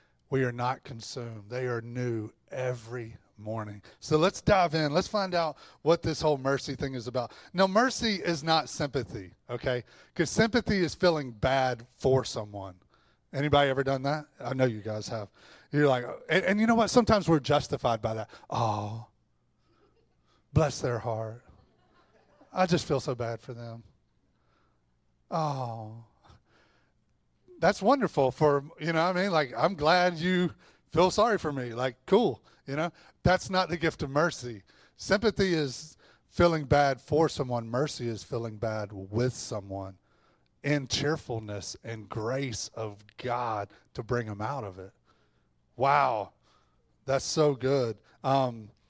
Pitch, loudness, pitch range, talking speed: 130 Hz, -29 LUFS, 115-160 Hz, 150 wpm